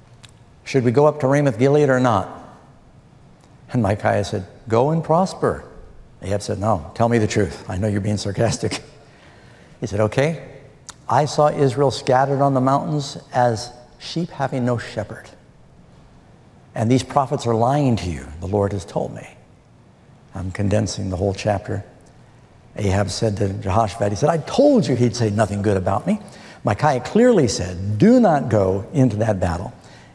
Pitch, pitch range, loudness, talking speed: 120 Hz, 105-140 Hz, -20 LUFS, 165 wpm